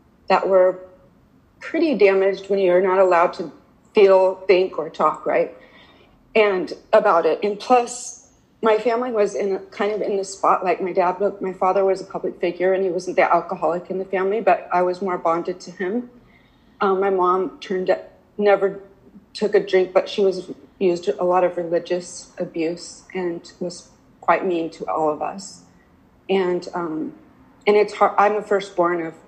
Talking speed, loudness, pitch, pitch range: 180 wpm, -20 LUFS, 190 Hz, 180-200 Hz